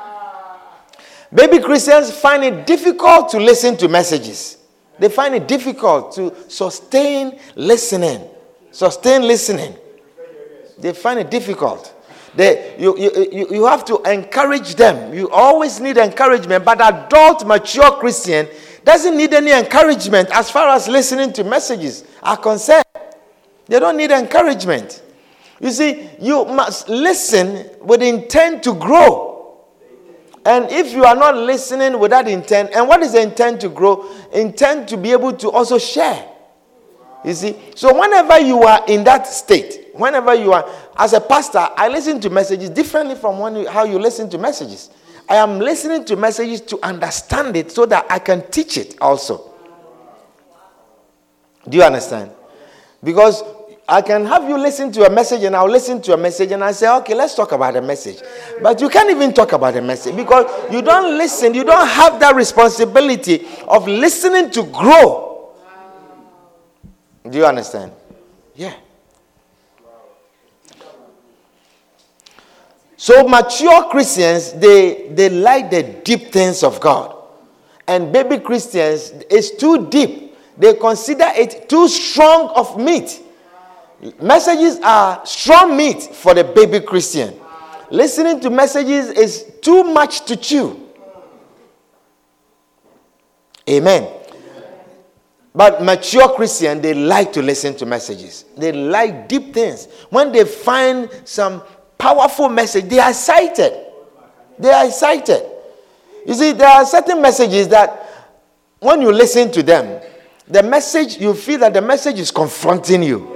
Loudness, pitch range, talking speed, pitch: -12 LUFS, 195-290 Hz, 140 wpm, 235 Hz